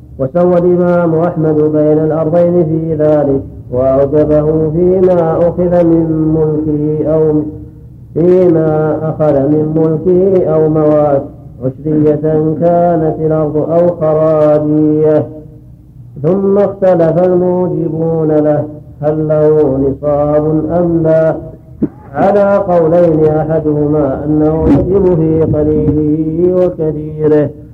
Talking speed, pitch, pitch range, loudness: 90 wpm, 155 Hz, 150-170 Hz, -11 LUFS